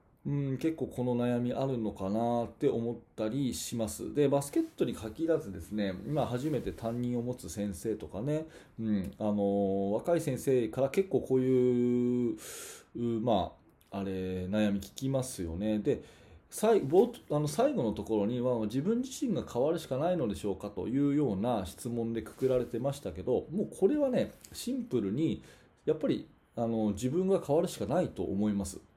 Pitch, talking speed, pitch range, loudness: 120 Hz, 330 characters per minute, 105-140 Hz, -32 LUFS